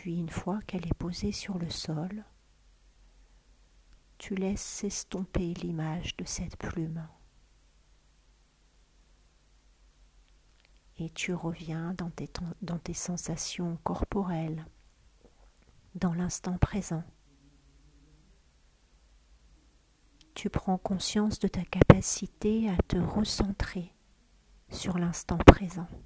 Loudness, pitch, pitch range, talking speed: -30 LUFS, 170 Hz, 145-185 Hz, 90 wpm